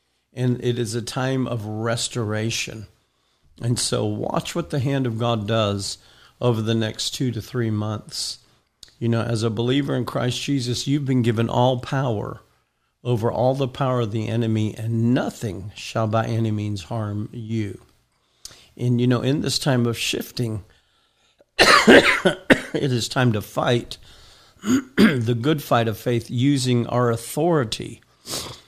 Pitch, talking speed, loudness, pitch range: 120 Hz, 150 wpm, -22 LUFS, 110-130 Hz